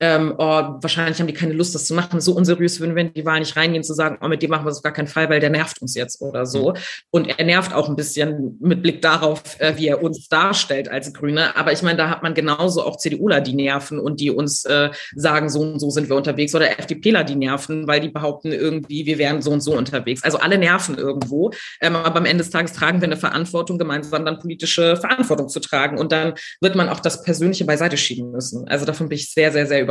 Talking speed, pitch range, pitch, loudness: 250 wpm, 145-165 Hz, 155 Hz, -19 LUFS